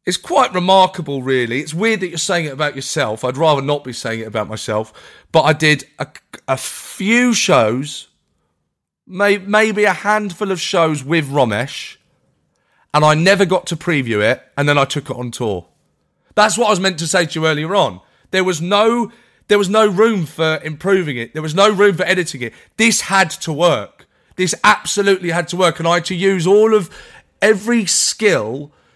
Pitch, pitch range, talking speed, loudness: 175 Hz, 145-200 Hz, 195 wpm, -15 LUFS